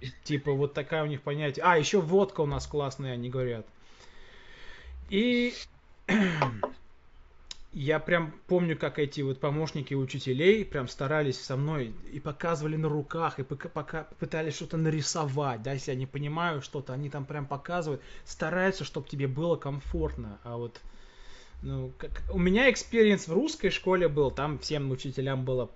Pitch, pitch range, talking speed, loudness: 150 Hz, 135-165 Hz, 155 wpm, -30 LUFS